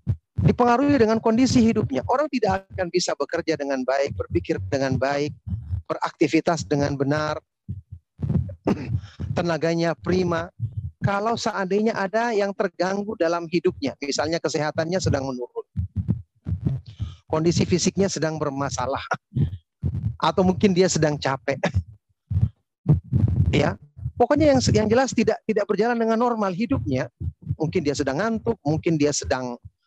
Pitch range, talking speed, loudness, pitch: 125-195 Hz, 115 wpm, -23 LUFS, 155 Hz